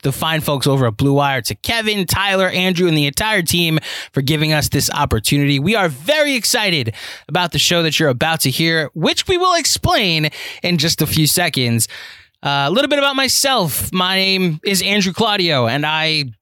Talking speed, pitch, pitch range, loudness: 195 wpm, 160 Hz, 140-190 Hz, -15 LUFS